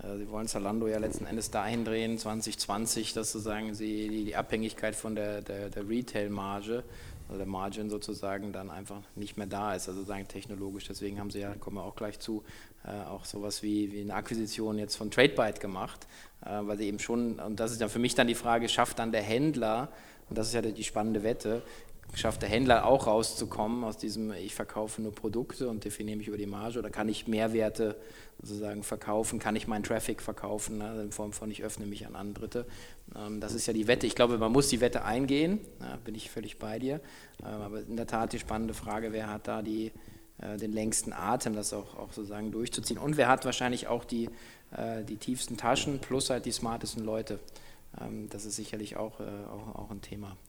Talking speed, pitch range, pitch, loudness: 200 wpm, 105-115 Hz, 110 Hz, -33 LUFS